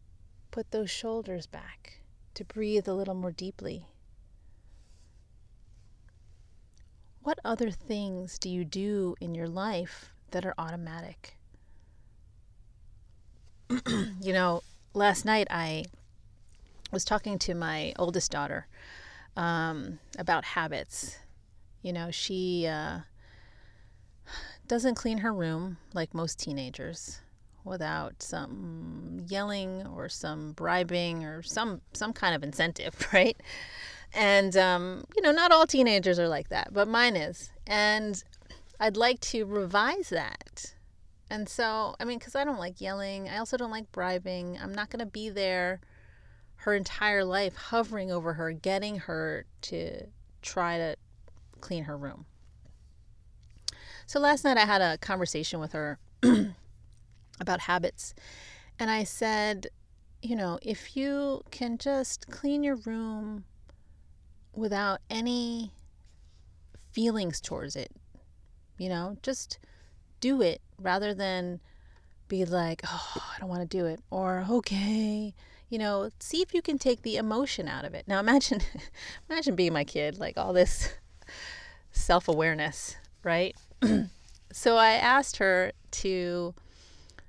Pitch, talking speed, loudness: 180 Hz, 130 wpm, -30 LUFS